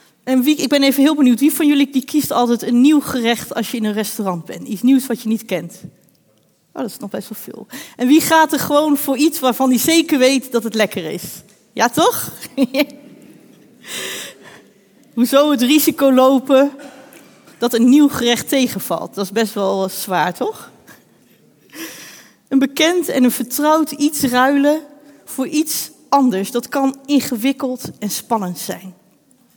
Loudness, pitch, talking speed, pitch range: -16 LUFS, 265 Hz, 170 wpm, 230-290 Hz